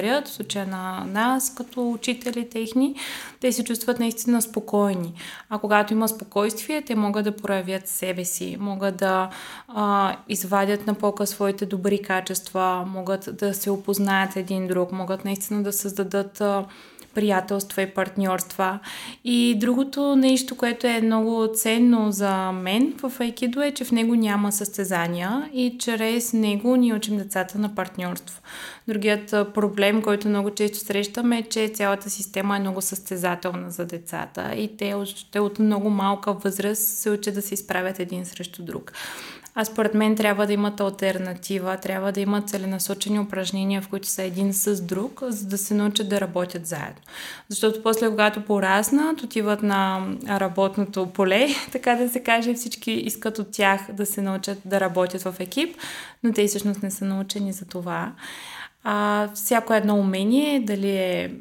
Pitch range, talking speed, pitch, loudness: 195-225 Hz, 155 wpm, 205 Hz, -24 LUFS